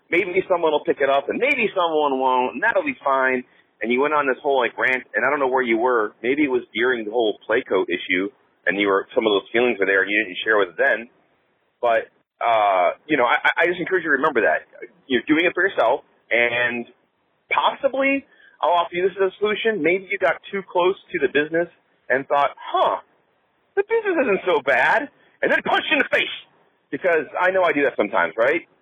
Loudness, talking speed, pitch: -20 LUFS, 230 wpm, 175 Hz